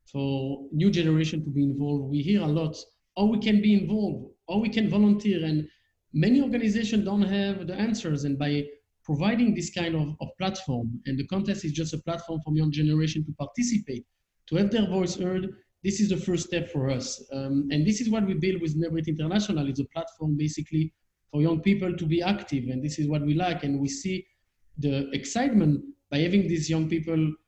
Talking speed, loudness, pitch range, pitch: 210 wpm, -27 LUFS, 150-195 Hz, 165 Hz